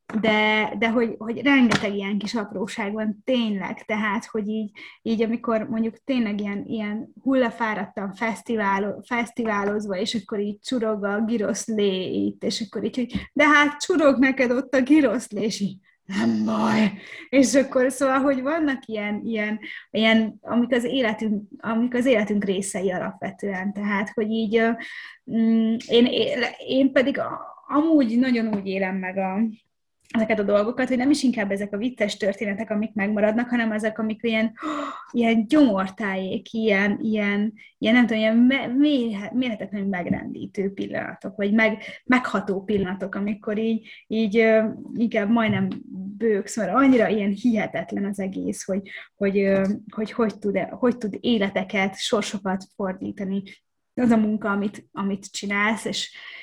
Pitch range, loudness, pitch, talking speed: 205-240 Hz, -23 LUFS, 220 Hz, 145 wpm